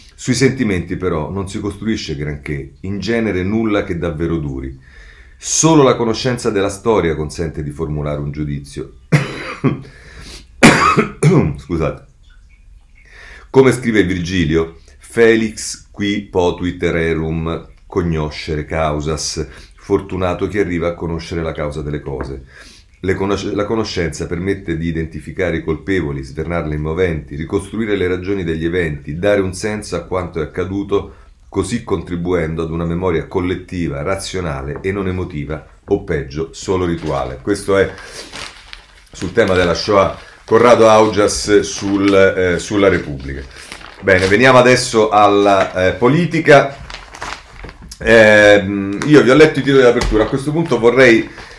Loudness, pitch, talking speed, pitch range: -15 LUFS, 90 Hz, 130 wpm, 80-100 Hz